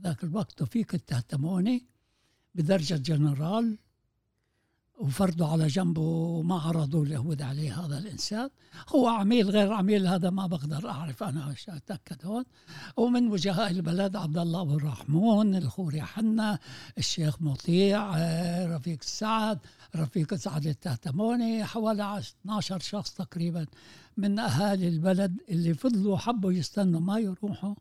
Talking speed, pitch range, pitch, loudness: 120 wpm, 155-205 Hz, 180 Hz, -29 LUFS